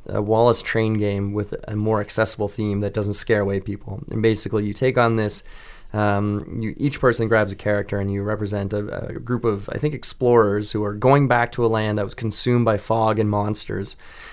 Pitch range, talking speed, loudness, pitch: 105-115 Hz, 215 wpm, -21 LUFS, 105 Hz